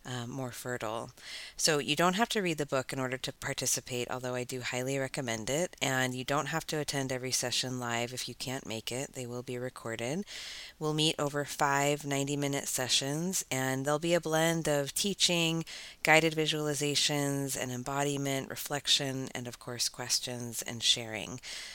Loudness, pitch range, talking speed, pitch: -31 LUFS, 125-150 Hz, 175 wpm, 135 Hz